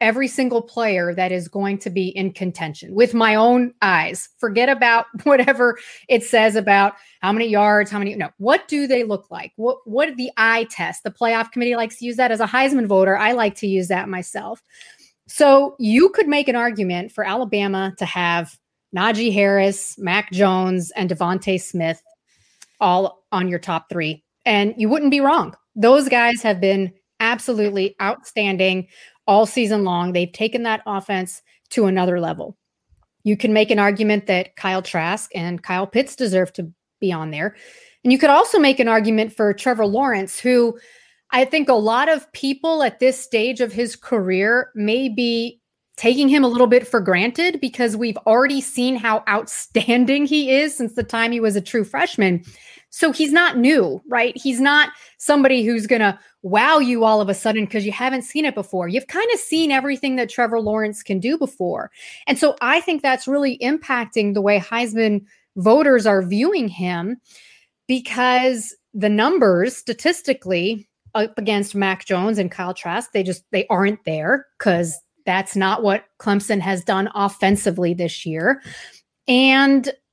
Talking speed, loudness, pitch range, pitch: 175 wpm, -18 LUFS, 195-255 Hz, 225 Hz